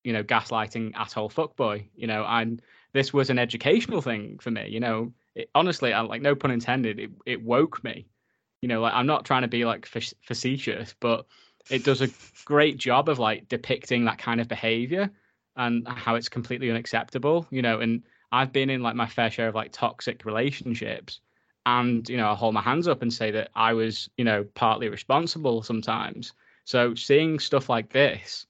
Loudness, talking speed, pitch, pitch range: -26 LUFS, 200 wpm, 120 Hz, 115-130 Hz